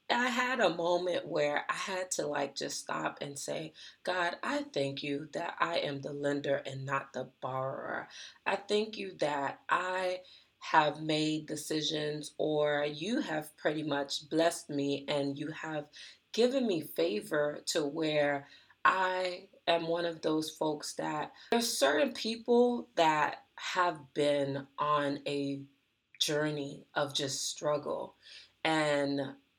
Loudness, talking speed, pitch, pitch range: -33 LUFS, 140 wpm, 150 Hz, 140-180 Hz